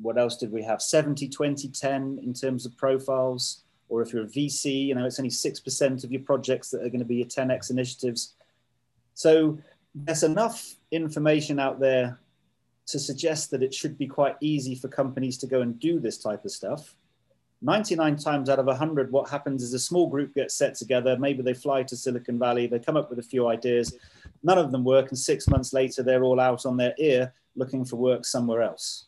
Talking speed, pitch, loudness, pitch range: 215 wpm, 130 Hz, -26 LUFS, 125-140 Hz